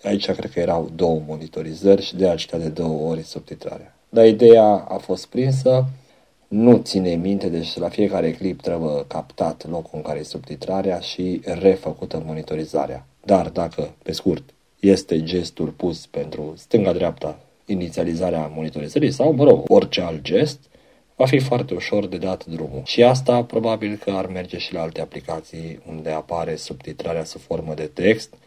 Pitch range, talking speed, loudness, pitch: 80-110 Hz, 160 wpm, -20 LUFS, 90 Hz